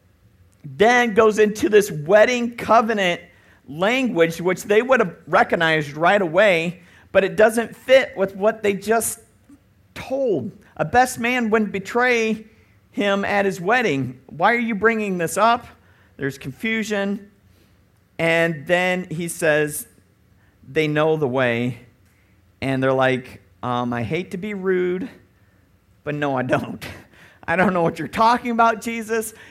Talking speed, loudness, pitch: 140 wpm, -20 LUFS, 180 Hz